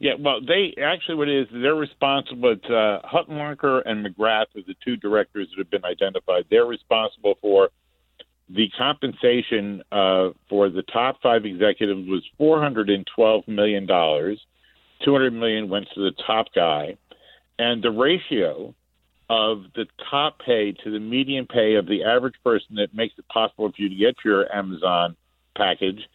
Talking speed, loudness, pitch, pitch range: 170 wpm, -22 LUFS, 110 Hz, 100-140 Hz